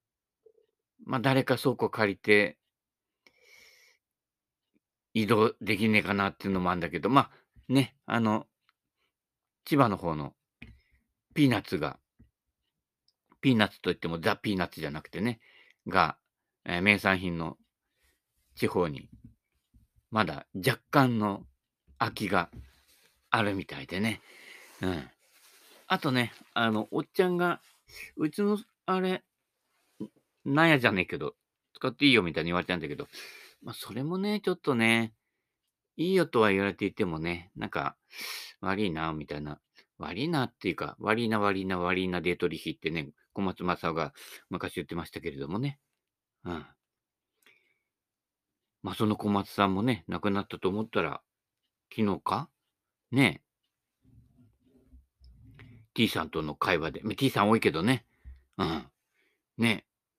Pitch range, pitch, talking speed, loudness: 90-130 Hz, 110 Hz, 260 characters per minute, -29 LUFS